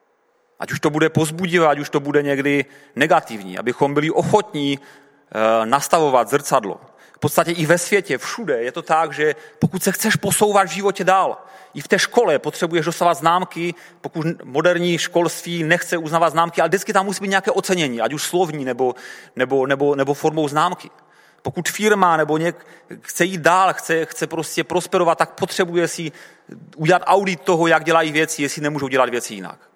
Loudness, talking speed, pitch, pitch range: -19 LUFS, 175 wpm, 165 Hz, 145-180 Hz